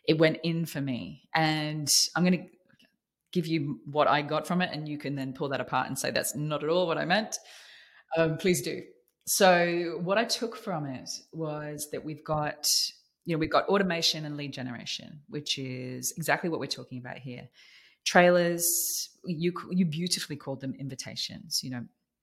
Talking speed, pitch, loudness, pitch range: 190 wpm, 155 Hz, -28 LUFS, 140-175 Hz